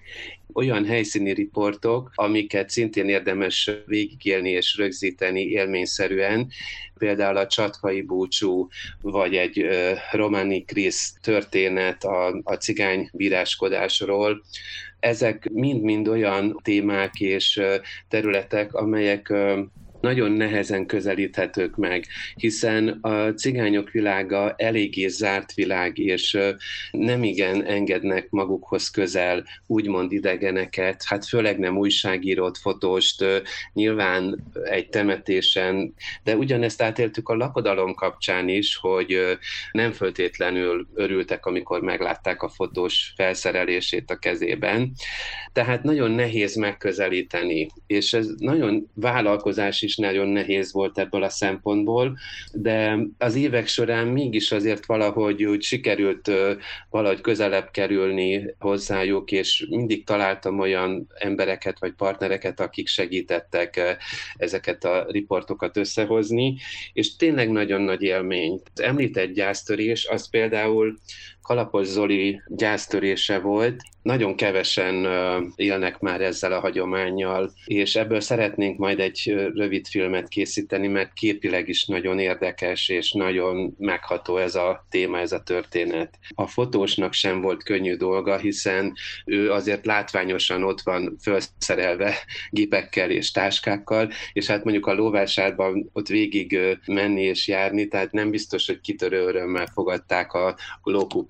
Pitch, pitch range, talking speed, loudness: 100 Hz, 95-110 Hz, 115 wpm, -23 LUFS